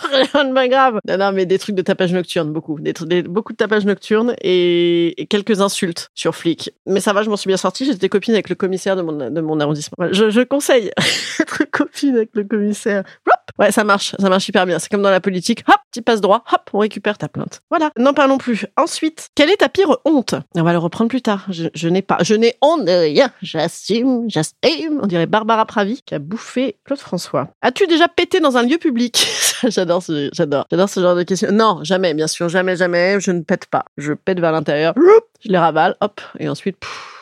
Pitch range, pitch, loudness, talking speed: 180-255 Hz, 205 Hz, -16 LUFS, 230 wpm